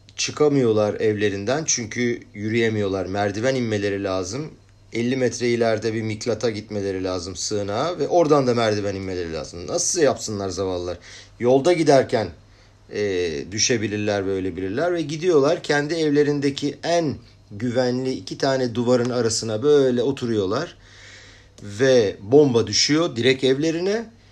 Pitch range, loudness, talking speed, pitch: 100-135 Hz, -21 LUFS, 115 wpm, 115 Hz